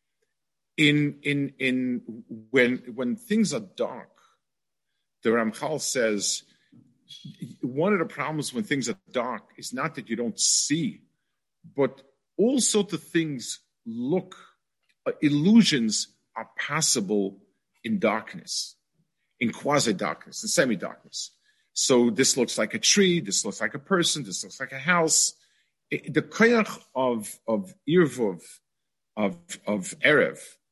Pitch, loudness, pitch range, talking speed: 165 Hz, -25 LUFS, 130-220 Hz, 135 wpm